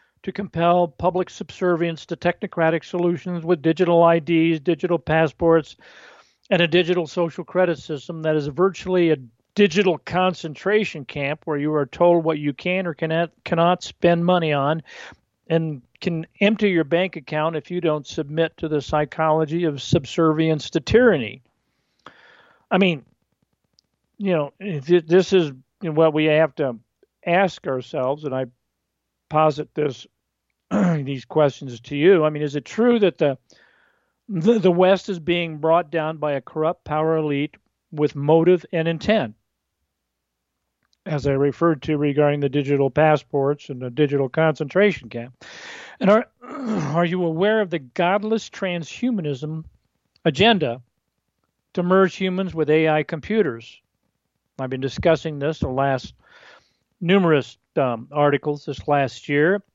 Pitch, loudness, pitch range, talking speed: 160 Hz, -21 LUFS, 145-180 Hz, 140 wpm